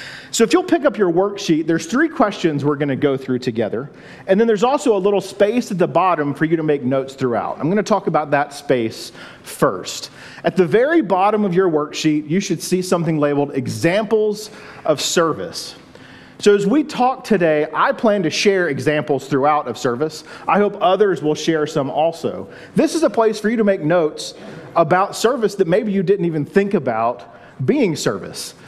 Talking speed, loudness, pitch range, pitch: 195 wpm, -18 LUFS, 150-205 Hz, 180 Hz